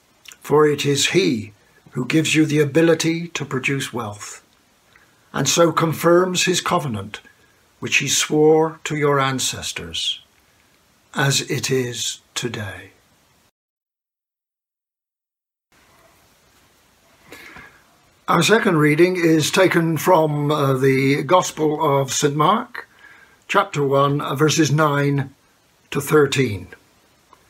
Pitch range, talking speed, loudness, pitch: 135-160 Hz, 100 wpm, -18 LUFS, 150 Hz